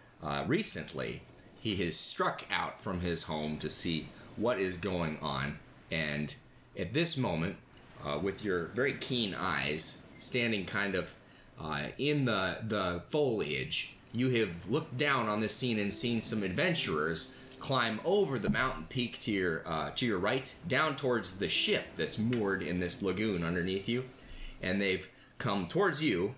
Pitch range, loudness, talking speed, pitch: 90-125 Hz, -32 LUFS, 160 wpm, 105 Hz